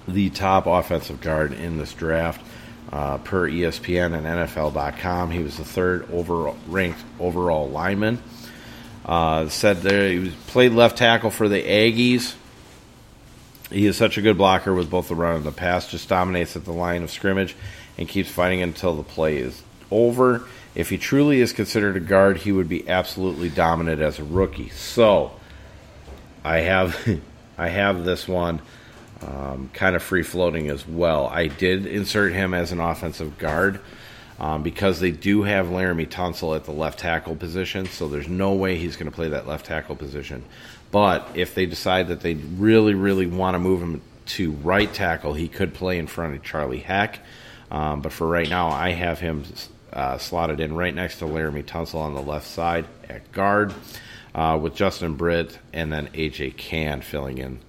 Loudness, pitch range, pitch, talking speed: -22 LUFS, 80-95 Hz, 90 Hz, 180 wpm